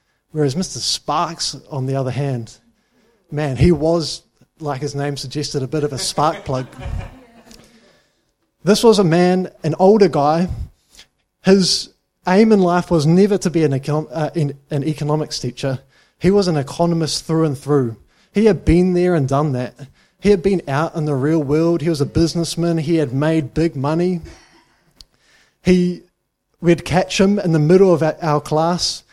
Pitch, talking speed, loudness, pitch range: 160 Hz, 170 wpm, -17 LUFS, 145-180 Hz